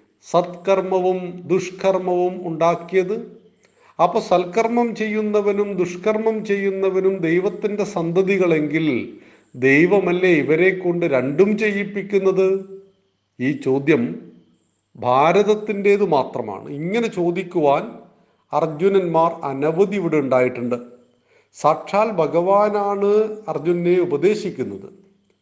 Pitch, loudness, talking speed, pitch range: 185 Hz, -19 LUFS, 65 wpm, 165-200 Hz